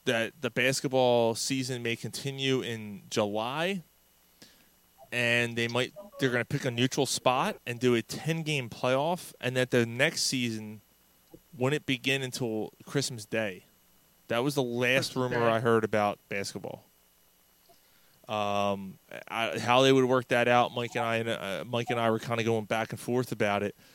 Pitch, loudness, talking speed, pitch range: 120 Hz, -29 LUFS, 160 wpm, 110-130 Hz